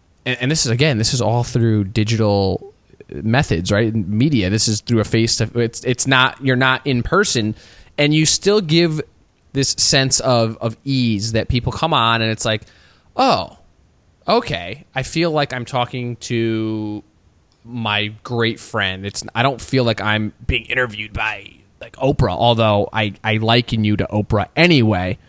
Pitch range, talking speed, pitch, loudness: 105-130 Hz, 170 wpm, 115 Hz, -17 LUFS